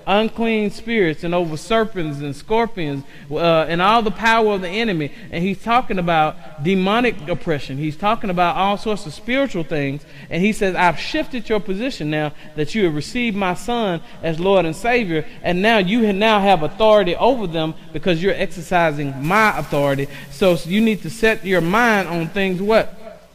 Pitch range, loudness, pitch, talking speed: 160-220 Hz, -19 LUFS, 185 Hz, 185 wpm